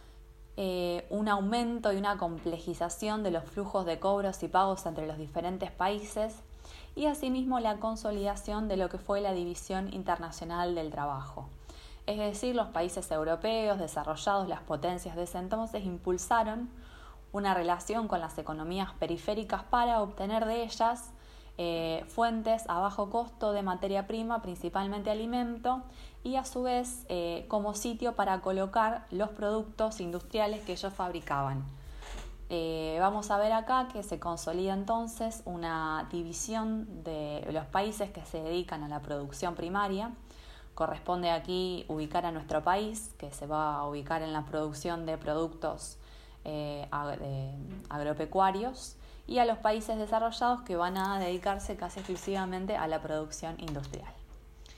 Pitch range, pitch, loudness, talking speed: 165-215 Hz, 190 Hz, -33 LUFS, 145 wpm